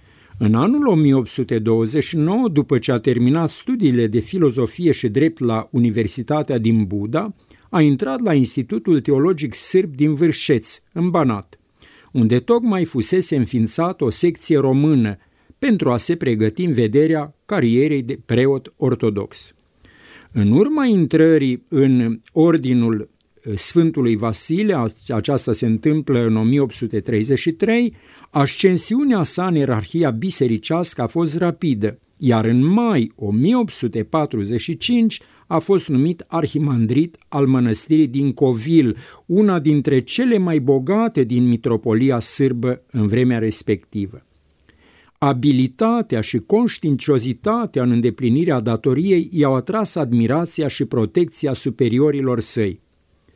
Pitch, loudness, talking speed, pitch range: 135 Hz, -18 LUFS, 110 wpm, 115-165 Hz